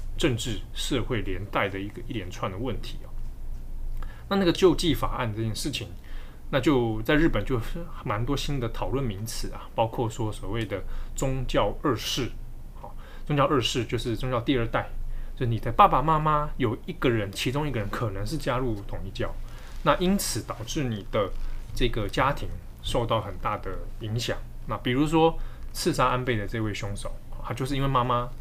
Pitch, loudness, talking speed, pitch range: 120 Hz, -27 LUFS, 270 characters per minute, 110-135 Hz